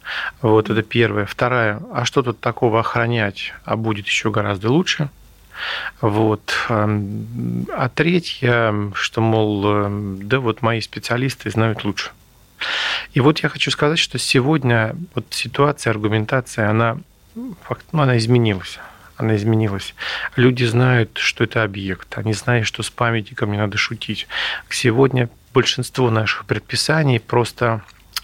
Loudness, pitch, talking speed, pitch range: -19 LUFS, 115 Hz, 125 wpm, 105-125 Hz